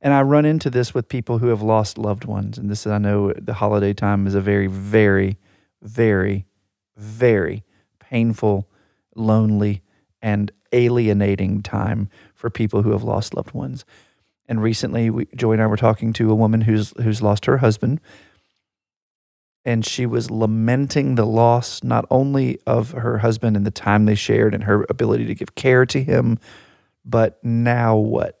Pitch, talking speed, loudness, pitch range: 110 Hz, 170 wpm, -19 LUFS, 100-120 Hz